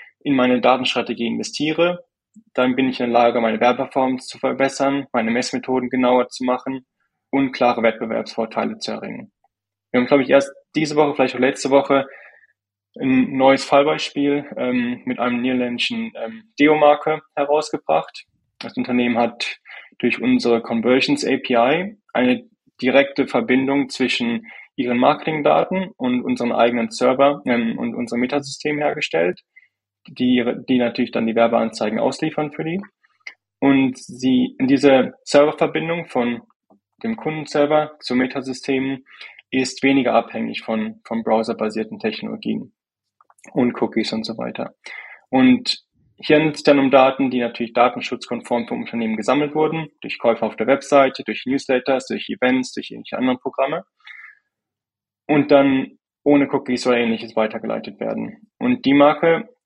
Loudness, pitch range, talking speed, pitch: -19 LUFS, 120-150 Hz, 135 wpm, 135 Hz